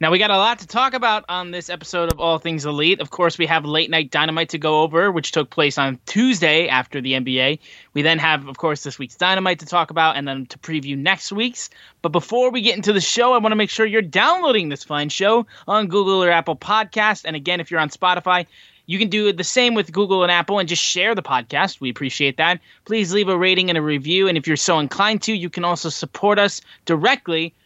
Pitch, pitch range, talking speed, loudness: 175 Hz, 155-200 Hz, 245 wpm, -18 LUFS